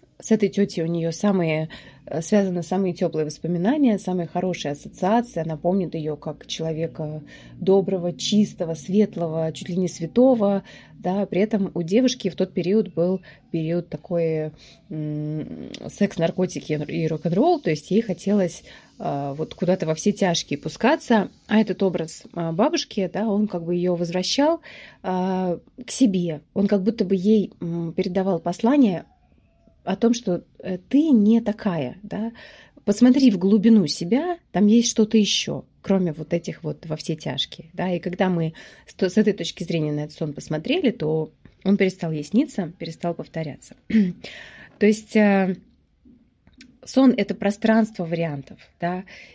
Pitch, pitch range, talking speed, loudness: 185 Hz, 165-210 Hz, 145 wpm, -22 LUFS